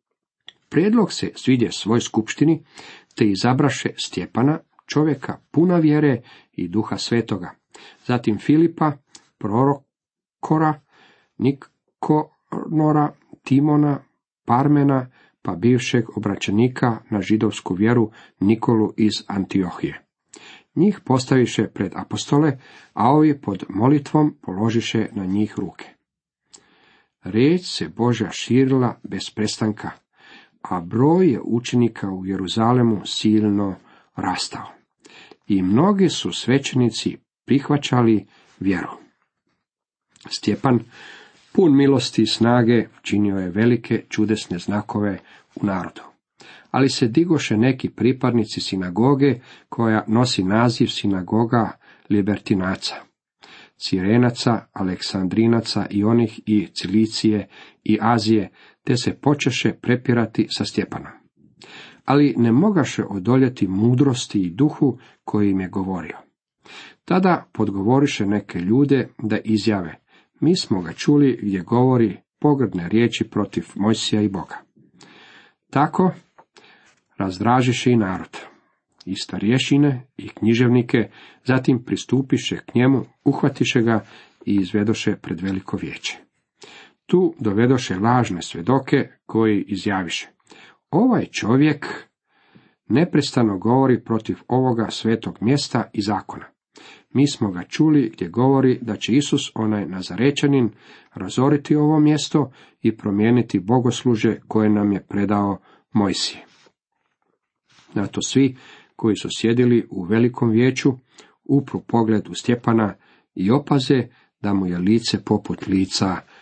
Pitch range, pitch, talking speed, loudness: 105-135 Hz, 115 Hz, 105 wpm, -20 LUFS